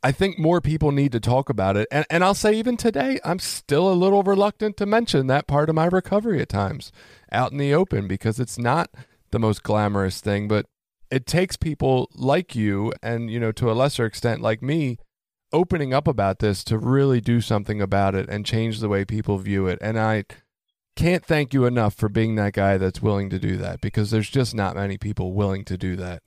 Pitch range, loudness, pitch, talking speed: 105-150 Hz, -22 LUFS, 115 Hz, 220 wpm